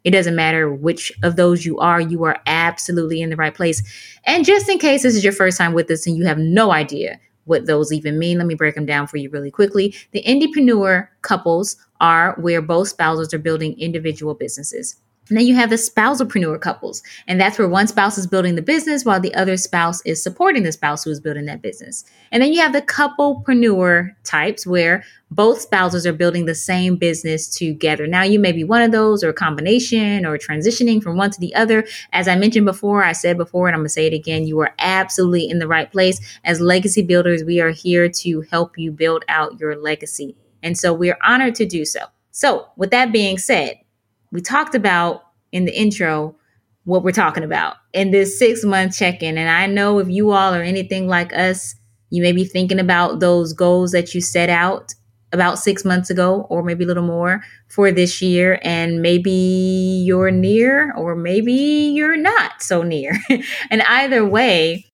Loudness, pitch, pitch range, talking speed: -16 LUFS, 180 Hz, 165-200 Hz, 210 wpm